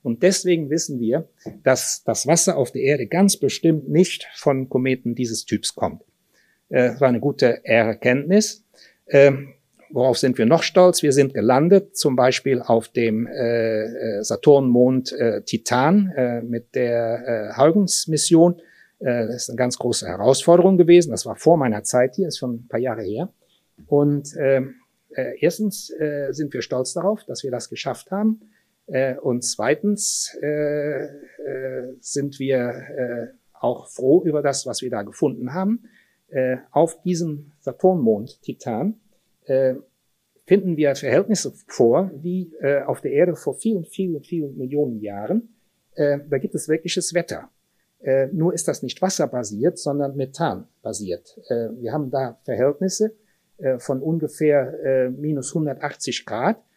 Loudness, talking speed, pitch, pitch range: -21 LUFS, 150 wpm, 145 Hz, 125-175 Hz